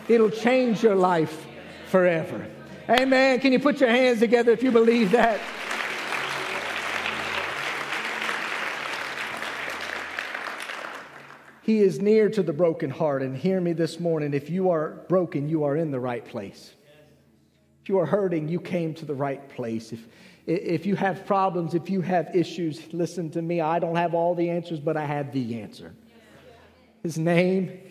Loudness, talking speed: -24 LUFS, 155 wpm